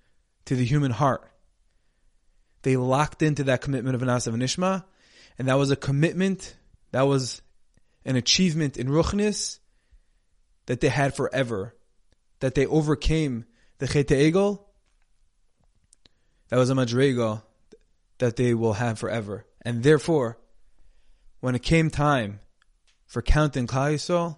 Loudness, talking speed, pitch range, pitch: -24 LUFS, 125 wpm, 115-150 Hz, 130 Hz